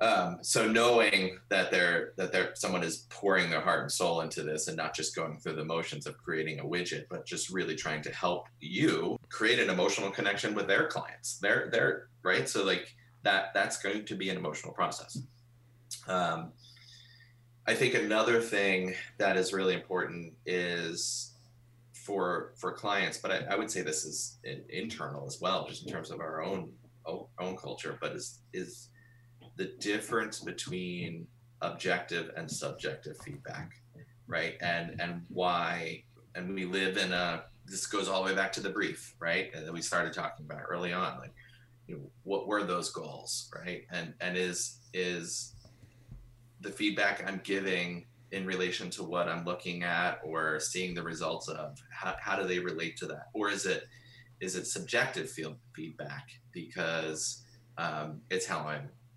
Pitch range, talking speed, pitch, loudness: 90-120 Hz, 175 wpm, 100 Hz, -33 LUFS